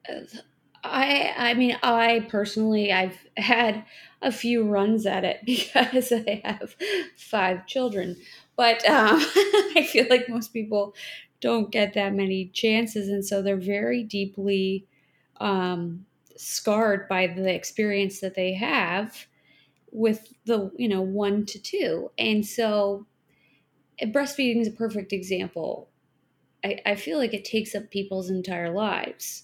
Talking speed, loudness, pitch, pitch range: 135 wpm, -25 LUFS, 210 Hz, 195-240 Hz